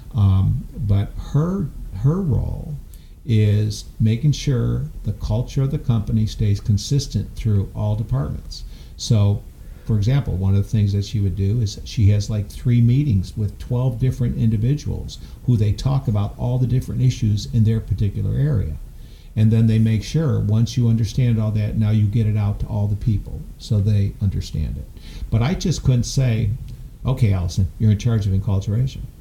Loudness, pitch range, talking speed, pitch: -21 LUFS, 100-125 Hz, 175 wpm, 110 Hz